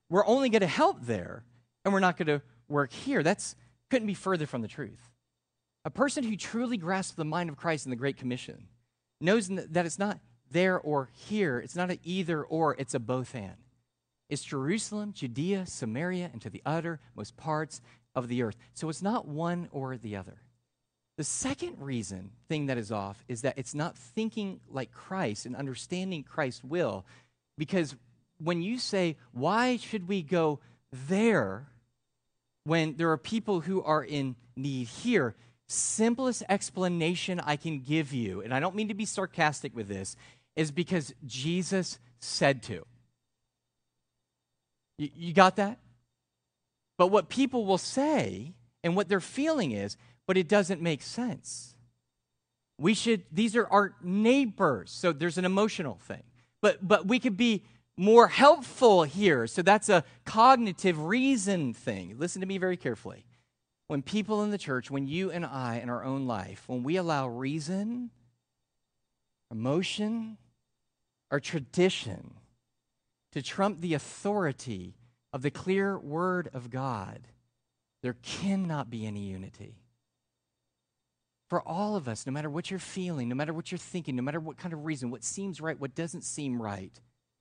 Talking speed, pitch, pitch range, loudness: 160 wpm, 155 Hz, 125-190 Hz, -30 LUFS